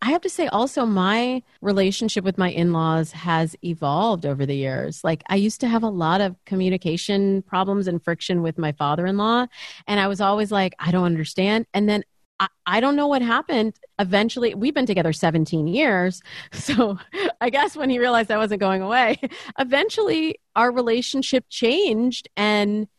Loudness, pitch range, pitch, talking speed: -21 LUFS, 180-245 Hz, 205 Hz, 175 wpm